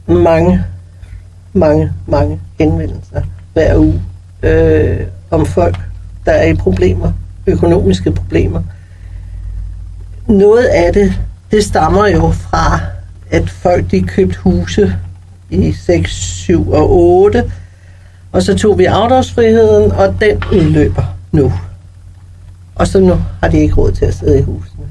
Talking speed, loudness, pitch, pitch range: 130 wpm, -11 LUFS, 90 Hz, 90-95 Hz